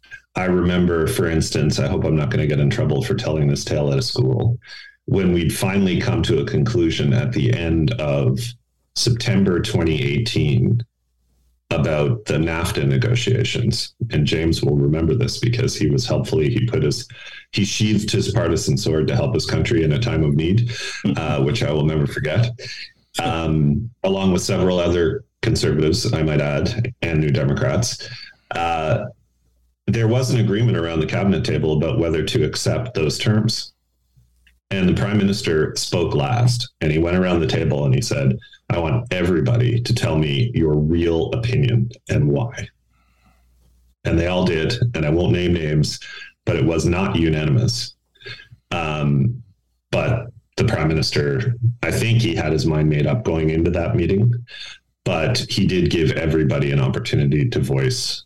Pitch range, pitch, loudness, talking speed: 75-120 Hz, 90 Hz, -19 LUFS, 165 wpm